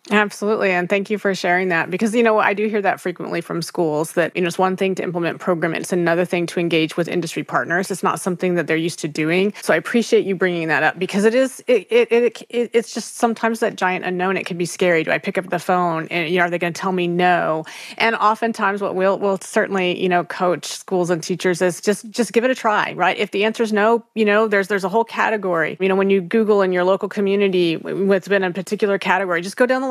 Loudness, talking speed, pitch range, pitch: -19 LUFS, 265 wpm, 175-215 Hz, 190 Hz